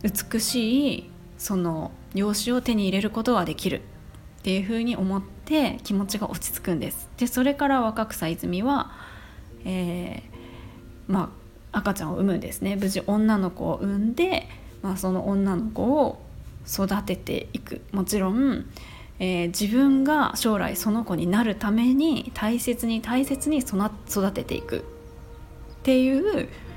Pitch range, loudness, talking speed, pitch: 190-245 Hz, -25 LUFS, 270 characters per minute, 210 Hz